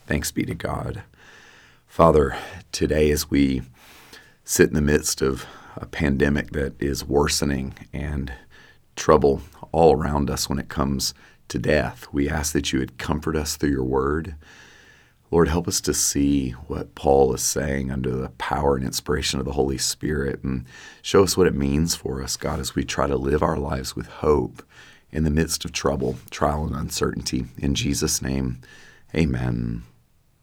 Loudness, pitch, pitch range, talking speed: -23 LUFS, 70 Hz, 65-75 Hz, 170 wpm